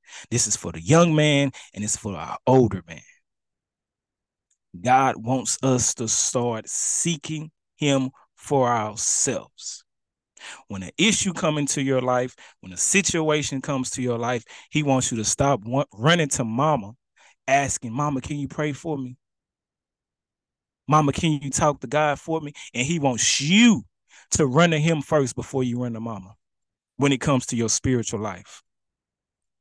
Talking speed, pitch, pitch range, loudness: 160 wpm, 130 Hz, 115-150 Hz, -22 LUFS